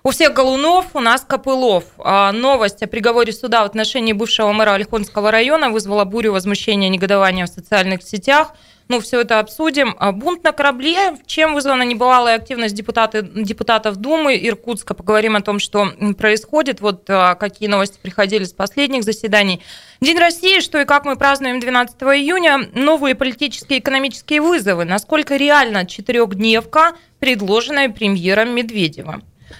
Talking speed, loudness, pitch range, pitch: 150 wpm, -15 LUFS, 210-275 Hz, 230 Hz